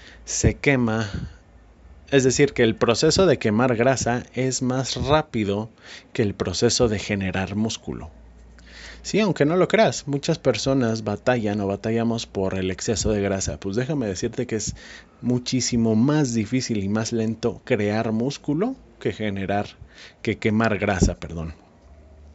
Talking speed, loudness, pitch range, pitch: 140 wpm, -23 LUFS, 95-125 Hz, 110 Hz